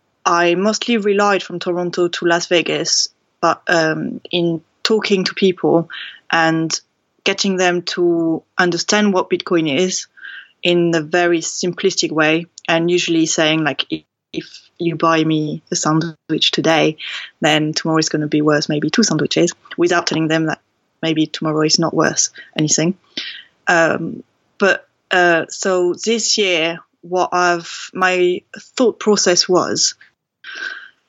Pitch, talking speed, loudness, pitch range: 175 Hz, 135 wpm, -16 LUFS, 160-185 Hz